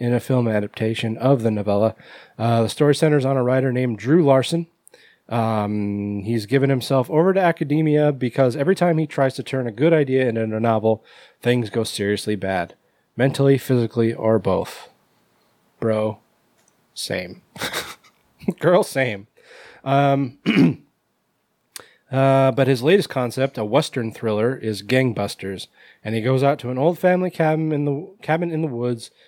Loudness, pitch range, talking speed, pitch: -20 LUFS, 115-145 Hz, 155 wpm, 130 Hz